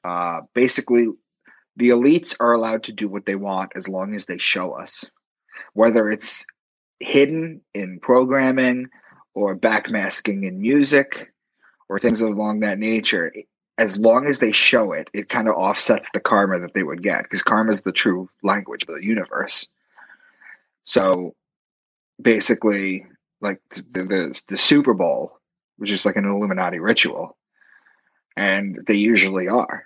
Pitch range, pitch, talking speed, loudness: 95-120 Hz, 105 Hz, 150 wpm, -20 LUFS